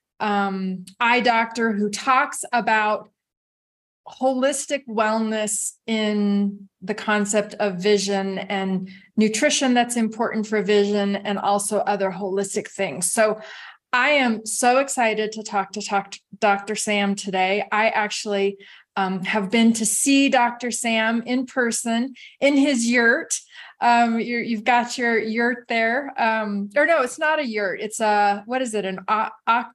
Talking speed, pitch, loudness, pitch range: 145 wpm, 215 Hz, -21 LUFS, 200-240 Hz